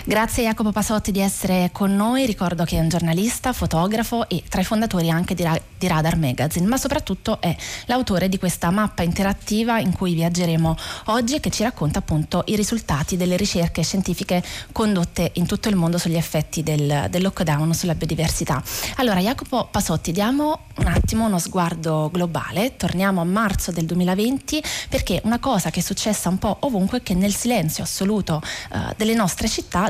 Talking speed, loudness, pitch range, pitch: 175 wpm, -21 LUFS, 170-220 Hz, 185 Hz